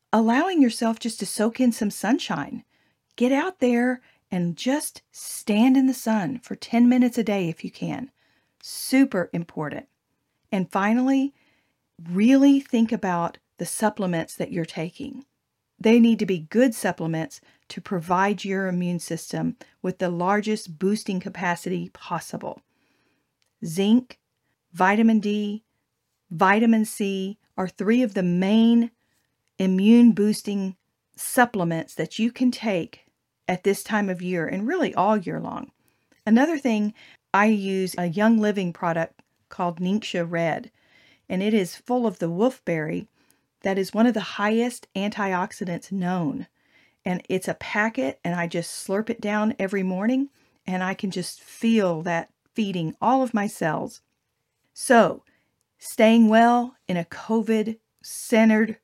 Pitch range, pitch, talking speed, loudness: 180-230 Hz, 205 Hz, 140 wpm, -23 LUFS